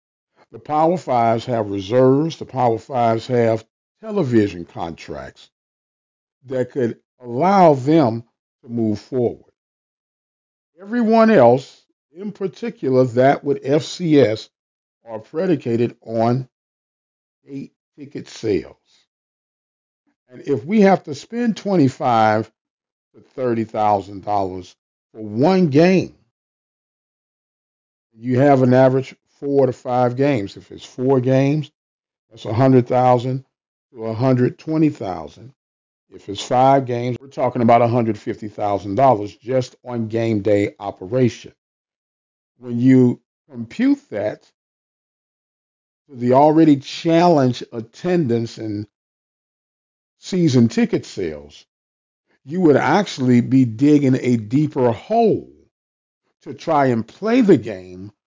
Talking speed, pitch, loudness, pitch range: 110 wpm, 125 Hz, -18 LUFS, 115-150 Hz